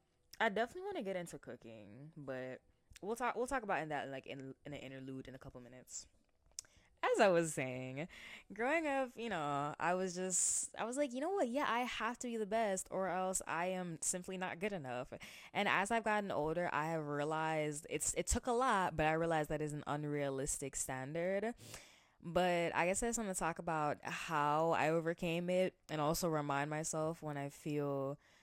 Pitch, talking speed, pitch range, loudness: 165 Hz, 205 wpm, 145-200 Hz, -38 LUFS